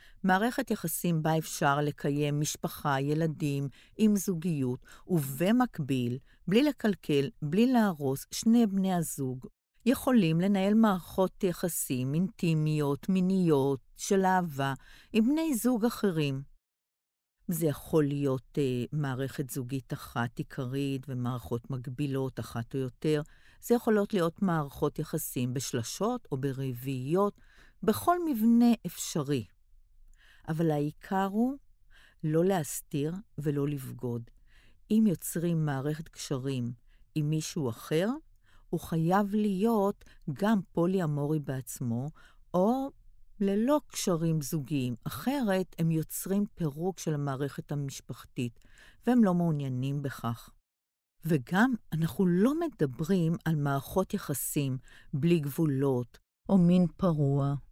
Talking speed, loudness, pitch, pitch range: 105 wpm, -30 LUFS, 155 Hz, 135-190 Hz